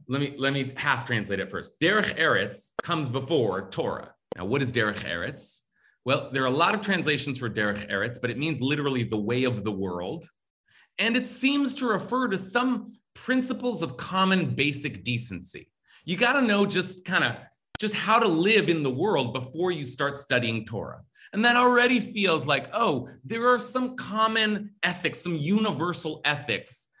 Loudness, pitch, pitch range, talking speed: -26 LUFS, 170 Hz, 135-220 Hz, 180 wpm